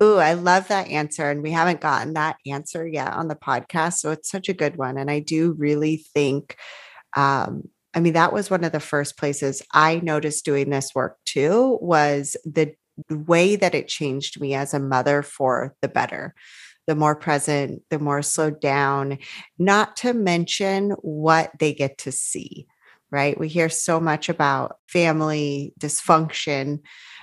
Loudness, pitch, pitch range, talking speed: -22 LUFS, 155 Hz, 145-165 Hz, 170 wpm